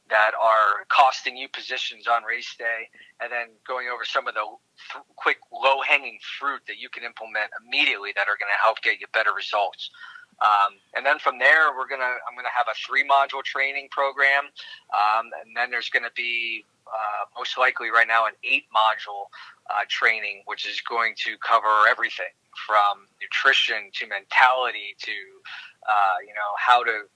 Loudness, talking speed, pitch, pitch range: -22 LUFS, 185 wpm, 125 Hz, 110-140 Hz